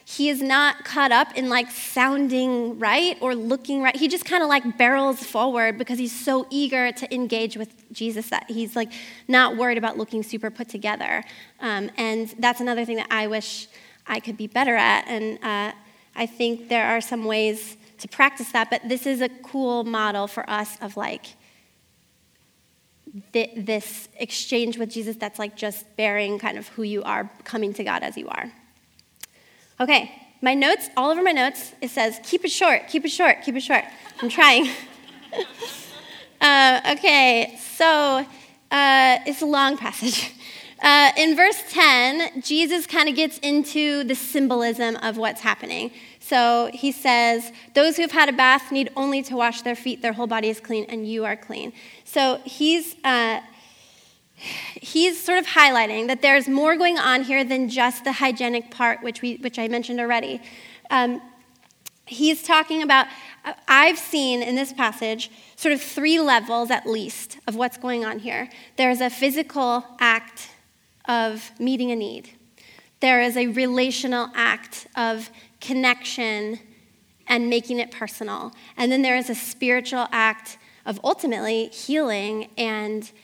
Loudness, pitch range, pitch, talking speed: -21 LUFS, 225-270 Hz, 245 Hz, 165 wpm